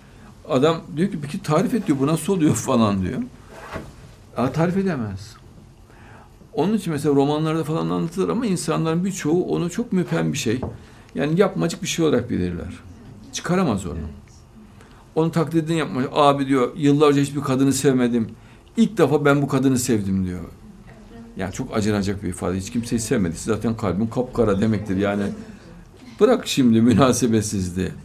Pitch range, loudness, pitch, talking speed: 110-160 Hz, -21 LUFS, 130 Hz, 150 wpm